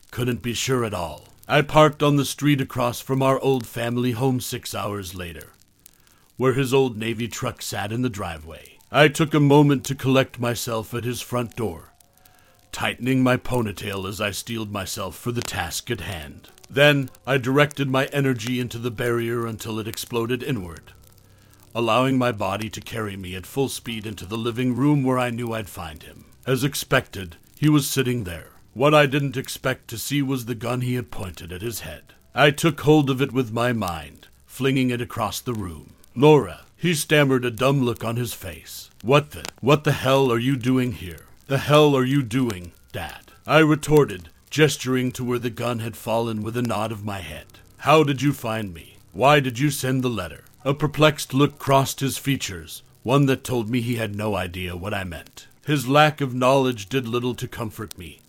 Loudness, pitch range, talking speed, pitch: -22 LUFS, 105-135 Hz, 200 wpm, 120 Hz